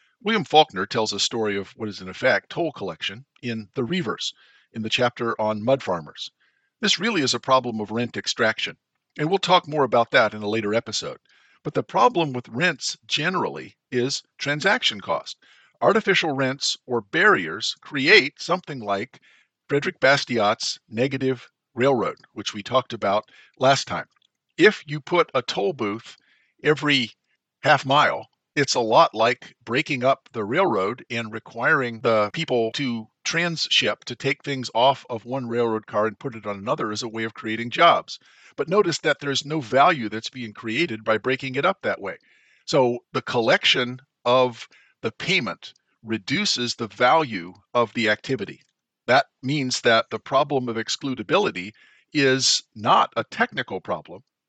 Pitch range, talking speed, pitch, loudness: 110-140 Hz, 160 wpm, 125 Hz, -22 LUFS